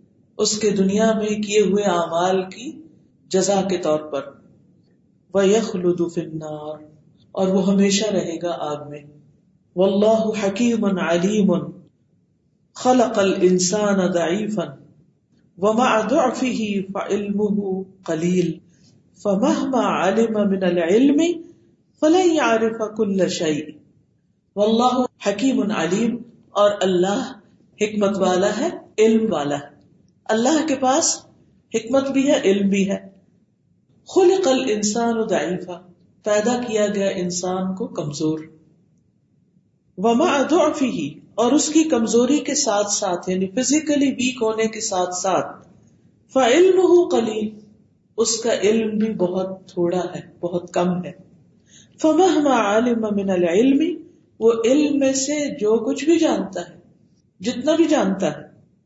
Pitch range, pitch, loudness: 180-240 Hz, 205 Hz, -20 LUFS